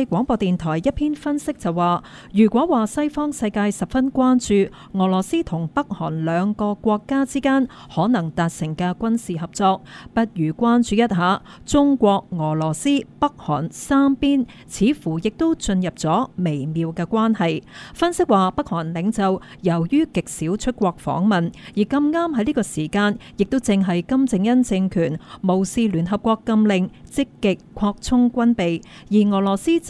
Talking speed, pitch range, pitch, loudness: 235 characters per minute, 175-255 Hz, 205 Hz, -20 LUFS